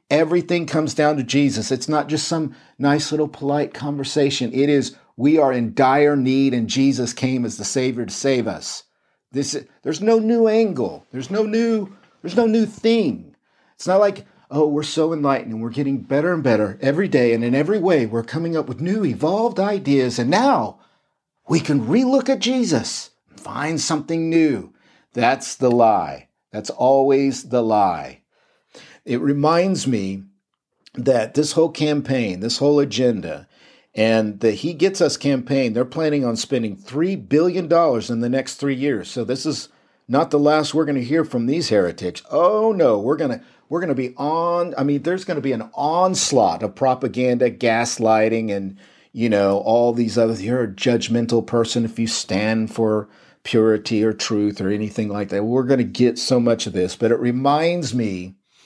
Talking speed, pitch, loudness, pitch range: 185 wpm, 135 Hz, -19 LUFS, 115-155 Hz